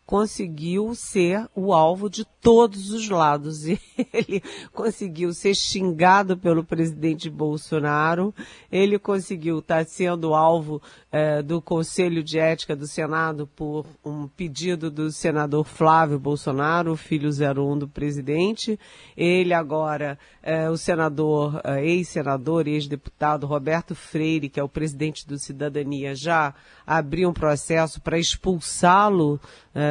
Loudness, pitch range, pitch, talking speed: -23 LUFS, 150-180 Hz, 160 Hz, 120 wpm